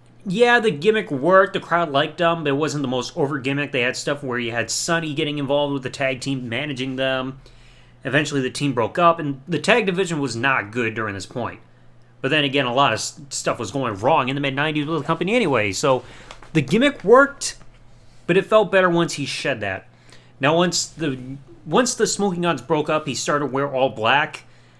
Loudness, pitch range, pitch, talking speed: -20 LUFS, 130-170 Hz, 145 Hz, 215 wpm